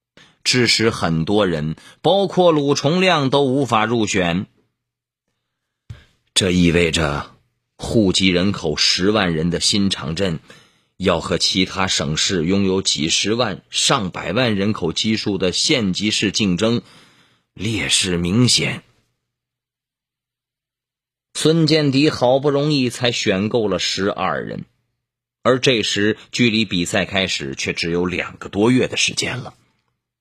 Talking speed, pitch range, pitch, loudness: 185 characters per minute, 90-130 Hz, 110 Hz, -18 LUFS